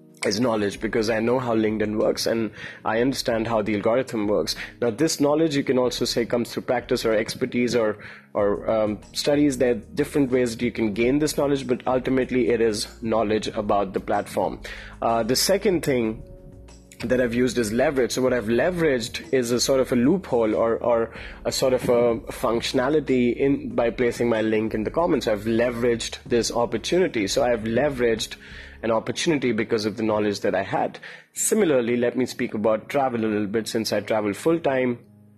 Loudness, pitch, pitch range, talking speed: -23 LUFS, 120 Hz, 110-130 Hz, 190 wpm